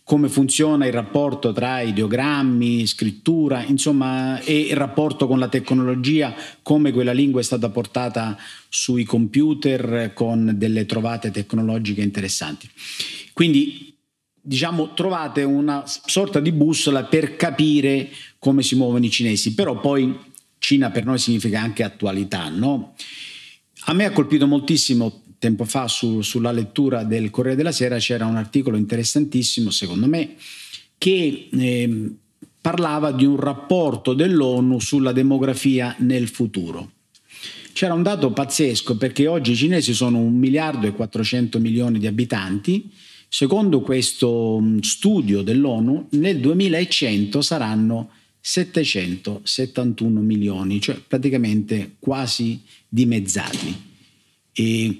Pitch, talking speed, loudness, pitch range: 125 Hz, 120 wpm, -20 LUFS, 110-145 Hz